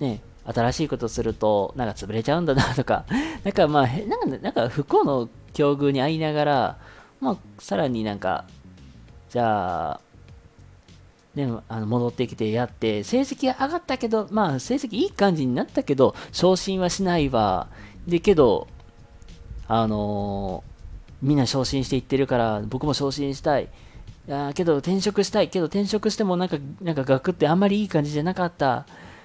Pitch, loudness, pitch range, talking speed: 135 Hz, -24 LUFS, 110-175 Hz, 320 characters per minute